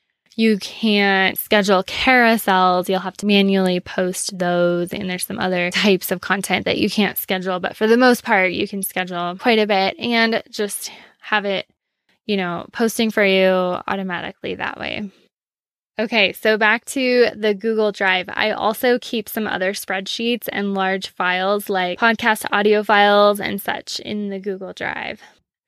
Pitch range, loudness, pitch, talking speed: 185-220 Hz, -18 LUFS, 200 Hz, 165 wpm